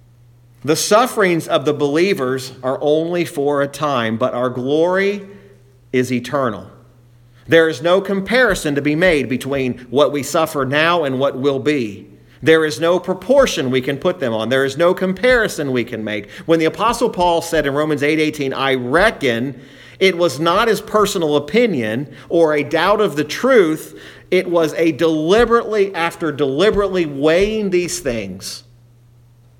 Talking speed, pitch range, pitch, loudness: 160 wpm, 130-175 Hz, 150 Hz, -16 LUFS